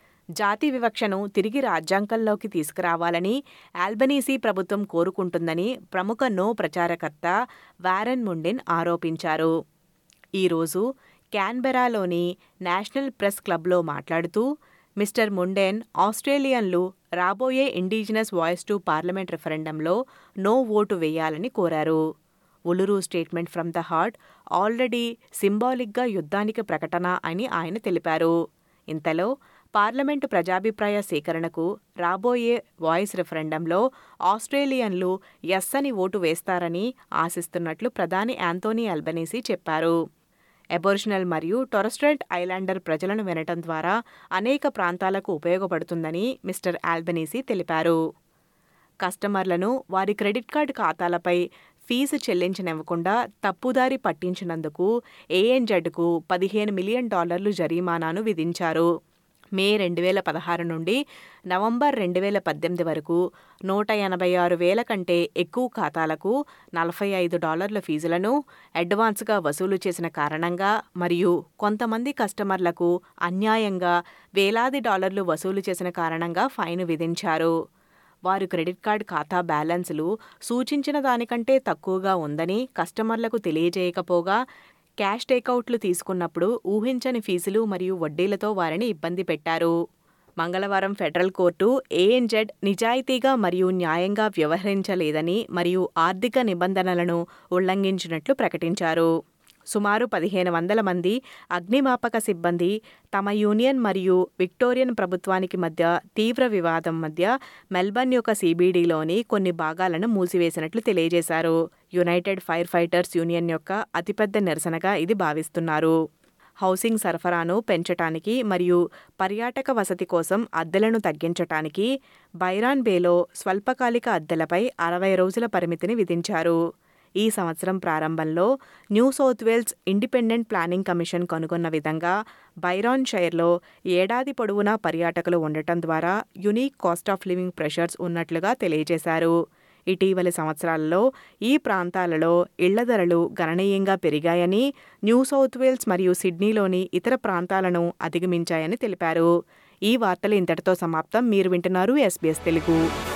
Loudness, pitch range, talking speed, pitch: -24 LUFS, 170-215 Hz, 100 wpm, 185 Hz